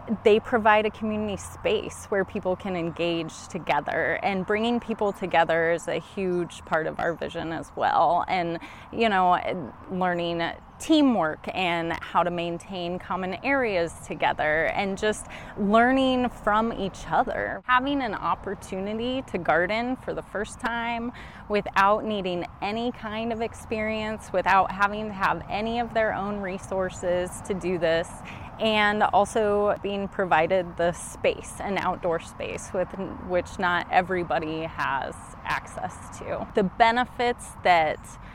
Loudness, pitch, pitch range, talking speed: -26 LUFS, 195 Hz, 180-220 Hz, 135 wpm